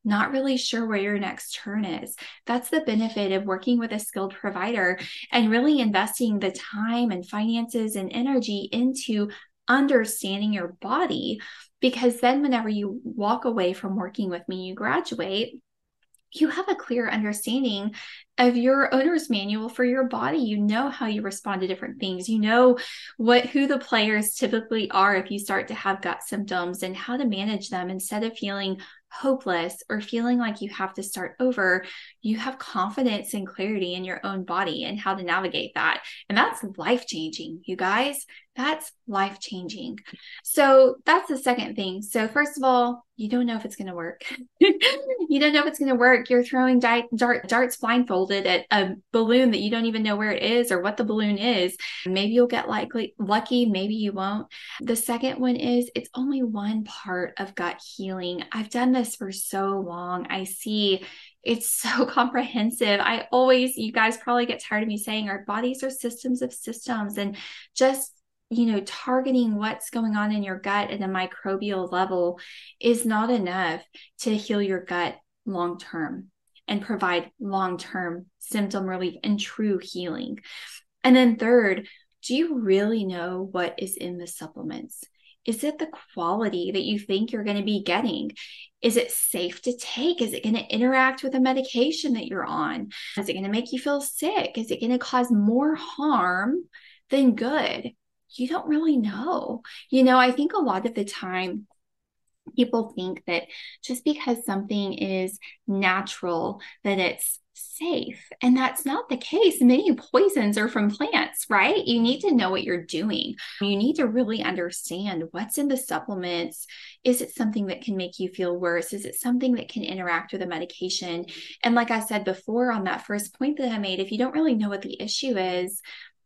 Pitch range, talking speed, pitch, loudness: 195-255 Hz, 185 wpm, 225 Hz, -25 LUFS